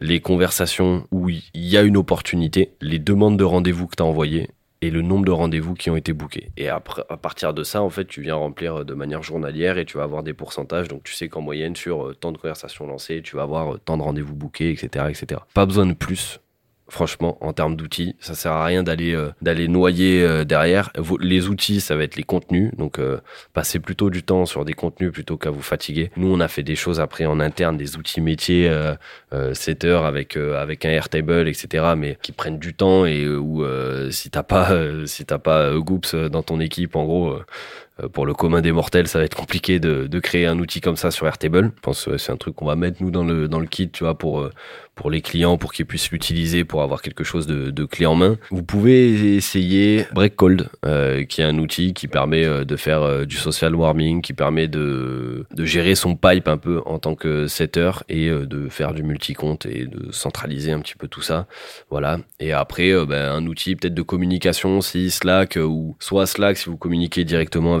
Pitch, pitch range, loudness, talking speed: 80 Hz, 75-90 Hz, -20 LUFS, 235 wpm